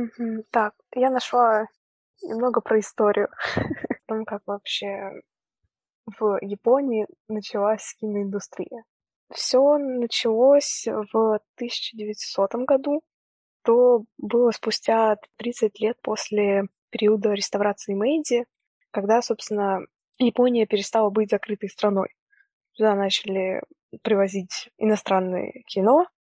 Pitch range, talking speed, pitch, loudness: 205-240 Hz, 95 wpm, 220 Hz, -23 LUFS